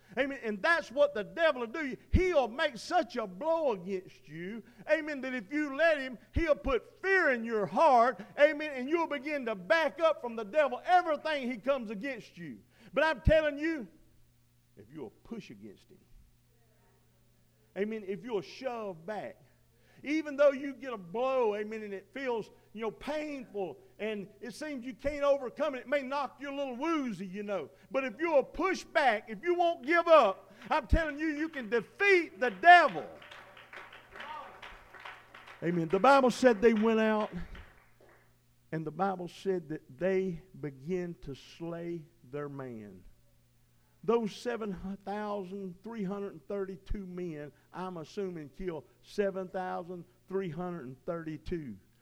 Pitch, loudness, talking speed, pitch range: 220 Hz, -31 LUFS, 150 wpm, 185-285 Hz